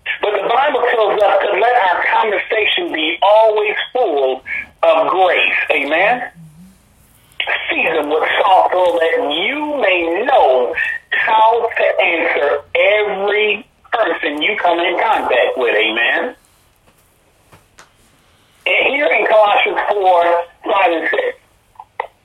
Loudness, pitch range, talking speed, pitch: -14 LUFS, 180-305 Hz, 115 wpm, 215 Hz